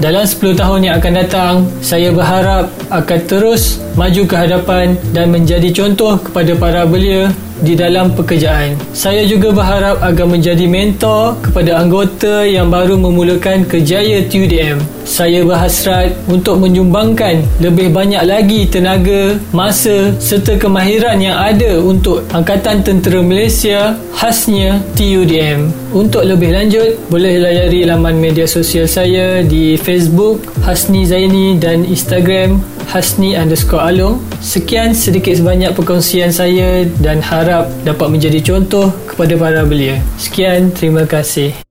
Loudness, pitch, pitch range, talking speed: -10 LUFS, 180 Hz, 170-195 Hz, 125 wpm